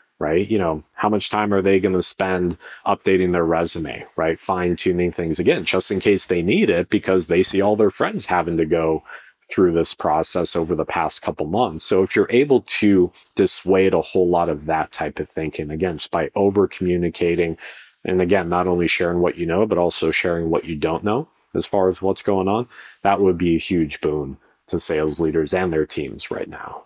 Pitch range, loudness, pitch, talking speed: 85-95 Hz, -20 LUFS, 90 Hz, 215 wpm